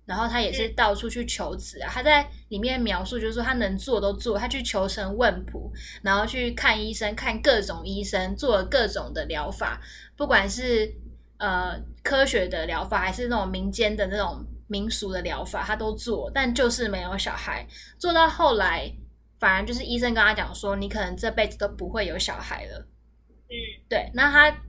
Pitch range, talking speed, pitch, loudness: 200-245 Hz, 275 characters per minute, 215 Hz, -25 LUFS